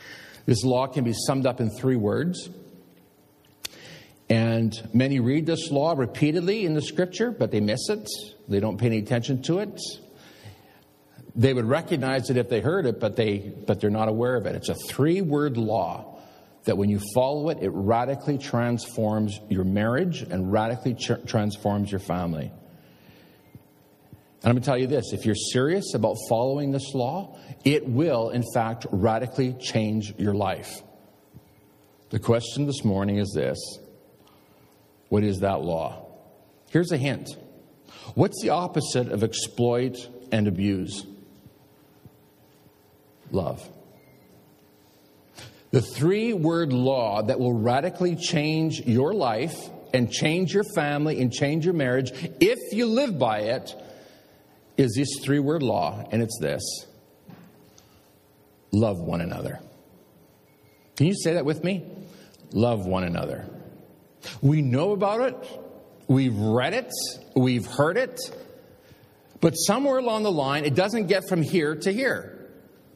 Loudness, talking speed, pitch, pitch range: -25 LUFS, 140 wpm, 125 Hz, 110-155 Hz